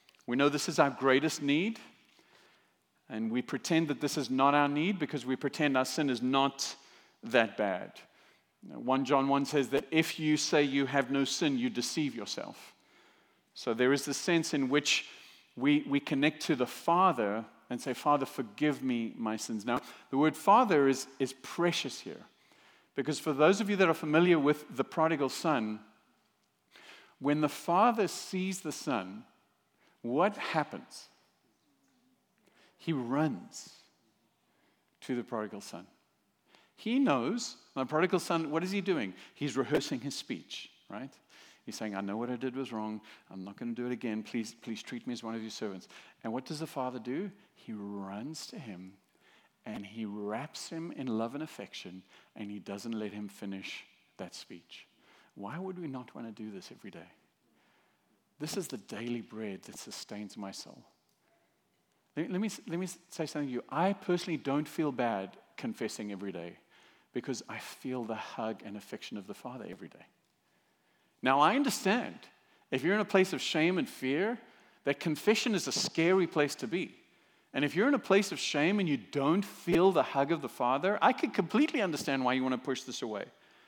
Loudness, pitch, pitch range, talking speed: -32 LUFS, 140 Hz, 120-165 Hz, 185 wpm